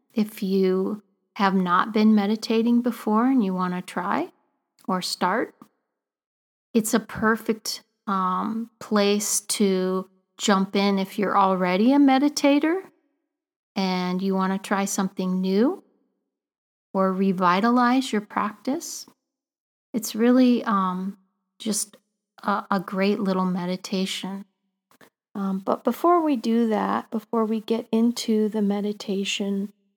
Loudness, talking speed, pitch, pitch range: -23 LUFS, 120 wpm, 210 Hz, 195-235 Hz